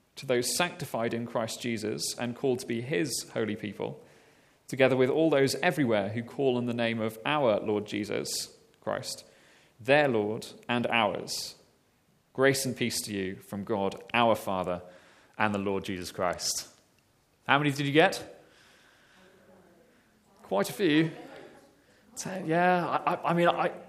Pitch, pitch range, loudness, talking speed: 120 Hz, 110-145 Hz, -29 LUFS, 150 wpm